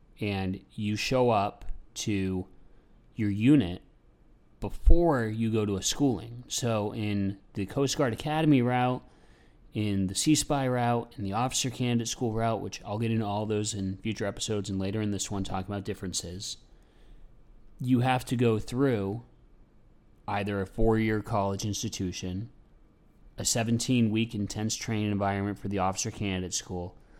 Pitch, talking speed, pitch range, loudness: 110 Hz, 150 wpm, 100-120 Hz, -29 LUFS